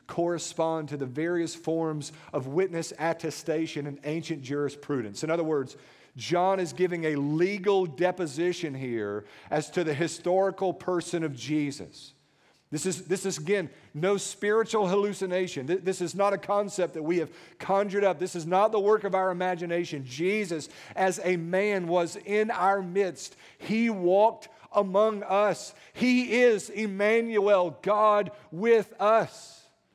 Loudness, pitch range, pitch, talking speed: -28 LUFS, 160-200 Hz, 180 Hz, 145 wpm